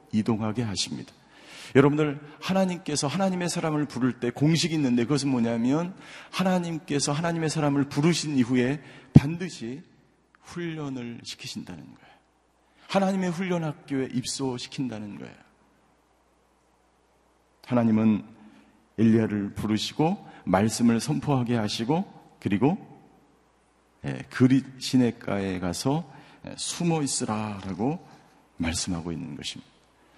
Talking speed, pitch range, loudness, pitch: 275 characters per minute, 115-155 Hz, -26 LUFS, 135 Hz